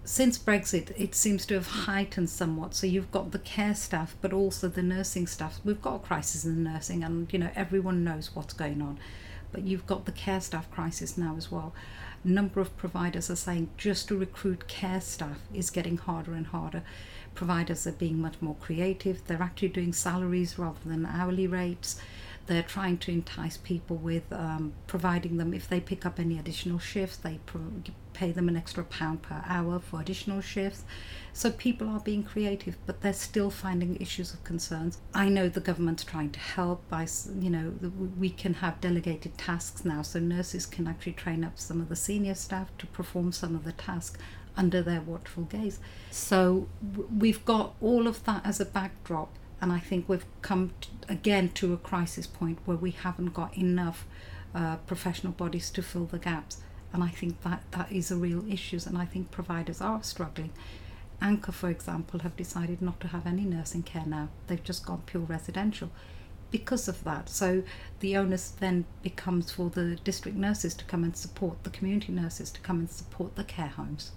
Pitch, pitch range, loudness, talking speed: 180 Hz, 165-190 Hz, -32 LUFS, 195 wpm